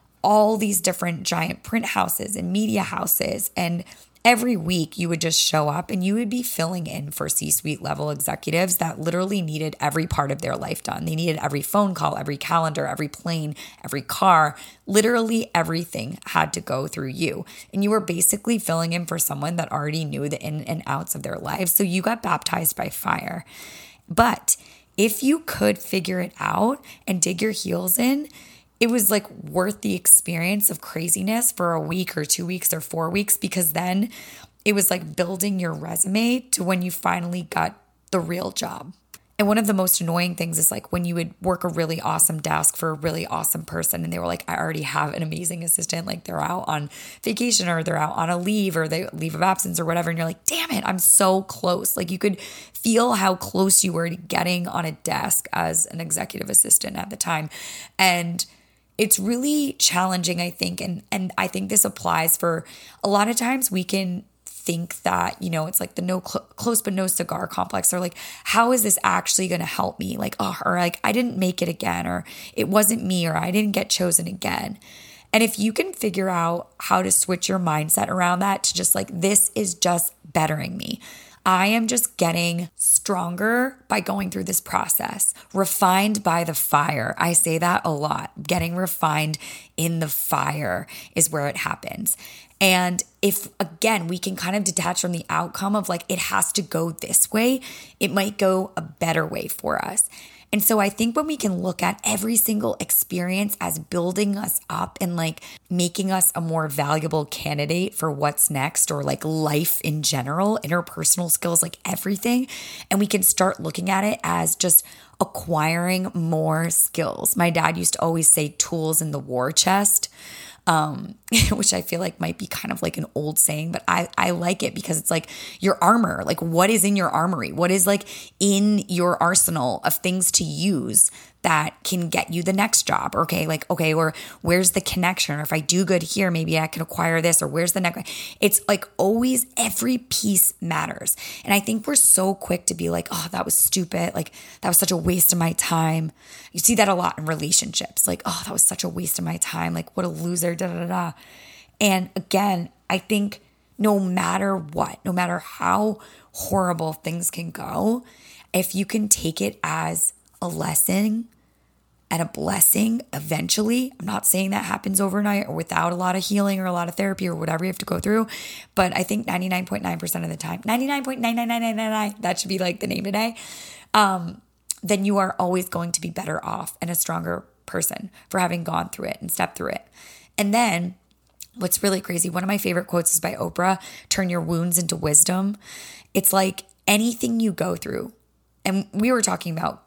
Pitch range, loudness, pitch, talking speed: 165-200 Hz, -21 LUFS, 180 Hz, 200 wpm